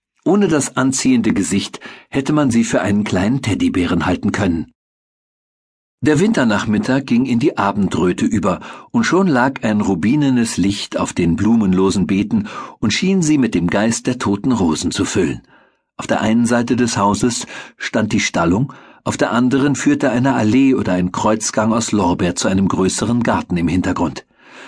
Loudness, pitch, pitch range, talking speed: -16 LUFS, 115 Hz, 100-135 Hz, 165 wpm